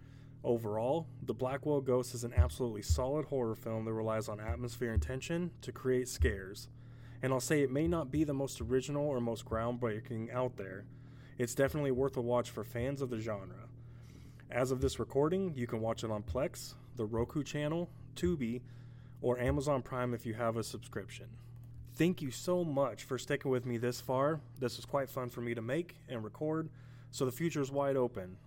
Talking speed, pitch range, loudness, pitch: 195 wpm, 120-135 Hz, -36 LUFS, 125 Hz